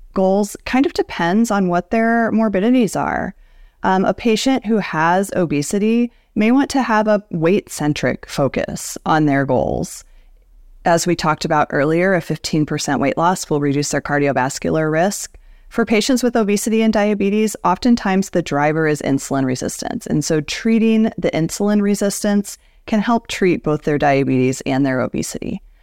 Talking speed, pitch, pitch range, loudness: 155 wpm, 185 Hz, 150-220 Hz, -17 LUFS